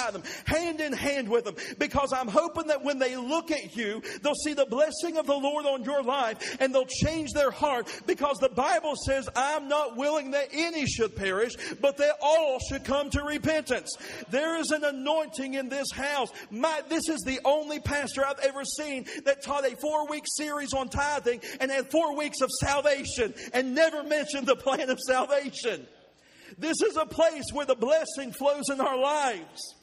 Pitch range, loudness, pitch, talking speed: 265-305 Hz, -28 LUFS, 285 Hz, 190 wpm